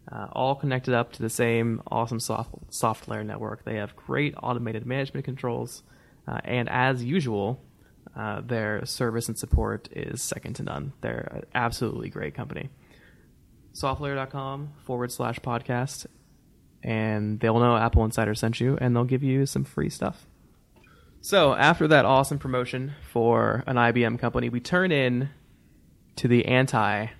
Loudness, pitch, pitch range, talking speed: -26 LUFS, 120 Hz, 115-130 Hz, 150 wpm